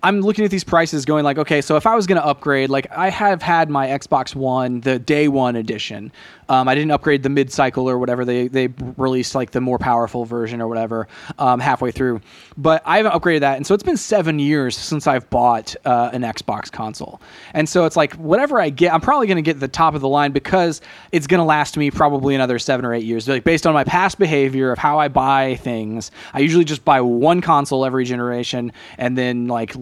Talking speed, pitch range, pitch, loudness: 235 wpm, 125-160 Hz, 140 Hz, -17 LUFS